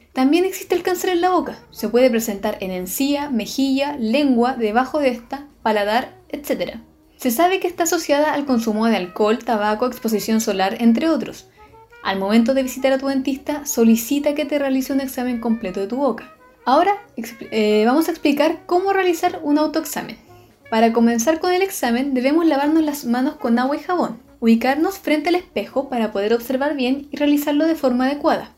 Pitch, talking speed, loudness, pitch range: 270 Hz, 180 wpm, -19 LUFS, 230-310 Hz